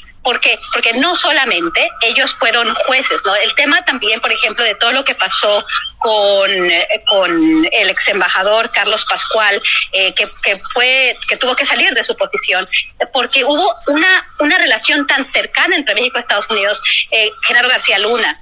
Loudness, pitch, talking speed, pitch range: -12 LUFS, 255 Hz, 175 wpm, 215-320 Hz